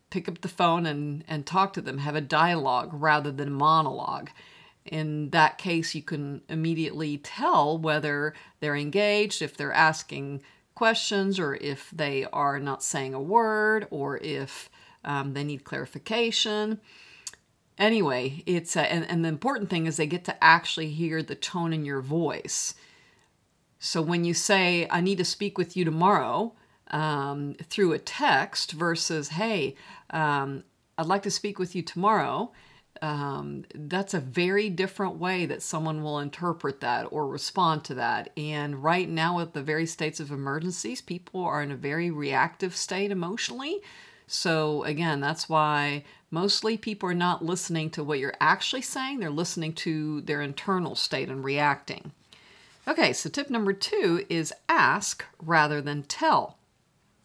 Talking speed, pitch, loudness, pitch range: 160 wpm, 165 Hz, -27 LUFS, 150-190 Hz